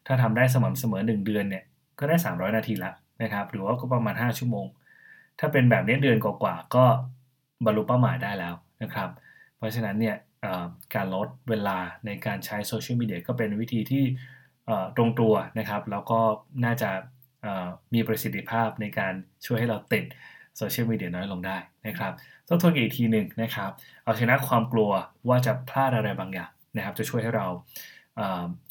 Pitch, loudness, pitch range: 110 Hz, -27 LUFS, 105-125 Hz